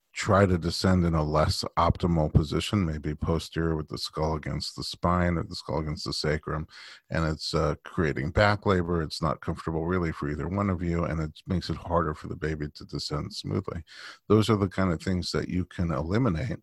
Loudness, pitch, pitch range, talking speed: -28 LUFS, 85 Hz, 80-95 Hz, 210 wpm